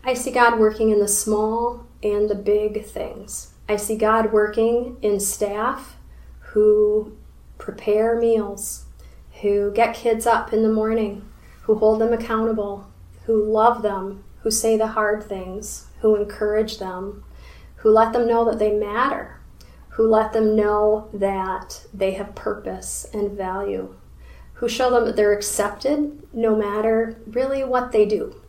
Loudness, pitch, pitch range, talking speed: -21 LUFS, 215 Hz, 205-230 Hz, 150 wpm